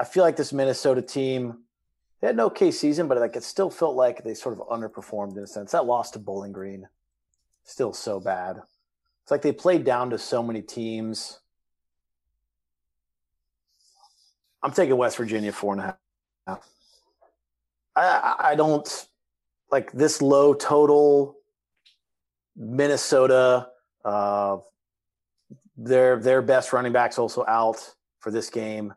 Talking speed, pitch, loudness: 145 wpm, 110 Hz, -23 LUFS